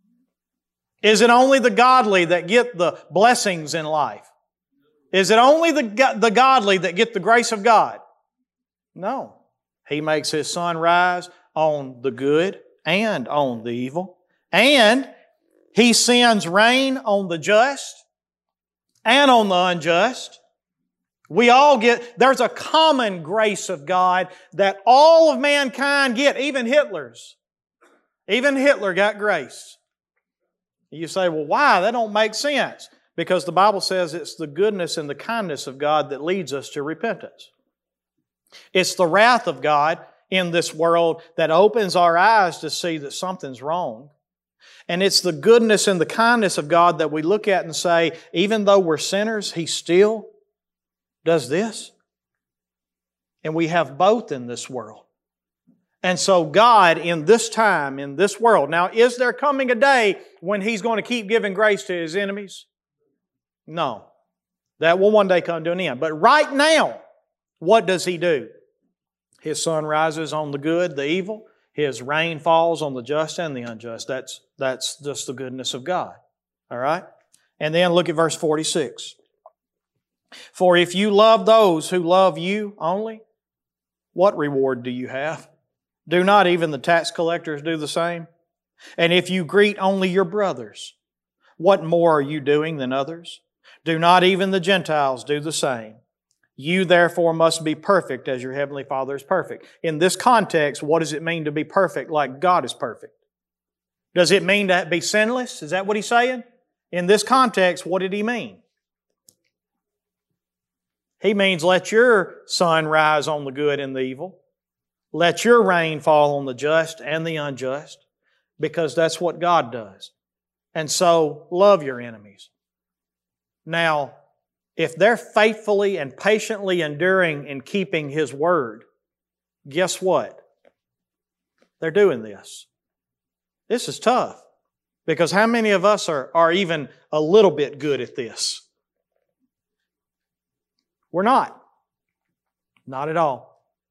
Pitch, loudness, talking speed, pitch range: 175 Hz, -19 LUFS, 155 wpm, 150-210 Hz